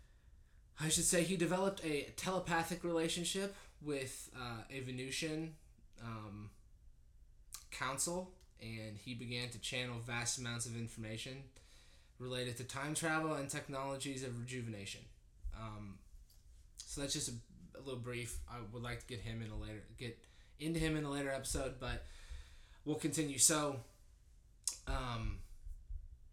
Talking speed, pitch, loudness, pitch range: 135 wpm, 120 Hz, -40 LUFS, 105-145 Hz